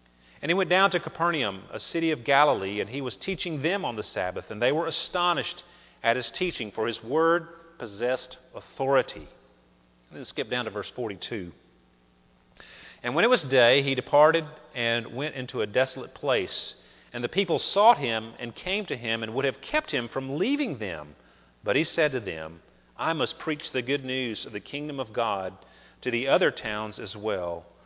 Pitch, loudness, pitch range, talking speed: 130 Hz, -27 LUFS, 95-155 Hz, 190 wpm